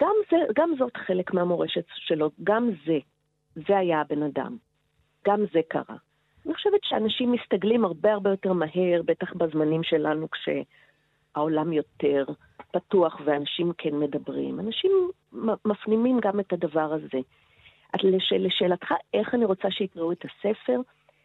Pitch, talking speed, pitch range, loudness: 180 Hz, 135 wpm, 155-210 Hz, -26 LUFS